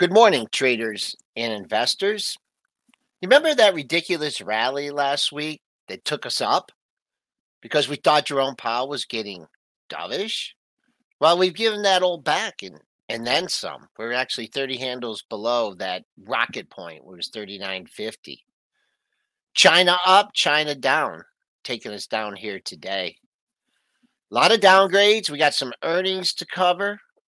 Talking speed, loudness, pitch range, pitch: 140 wpm, -21 LUFS, 135-205 Hz, 175 Hz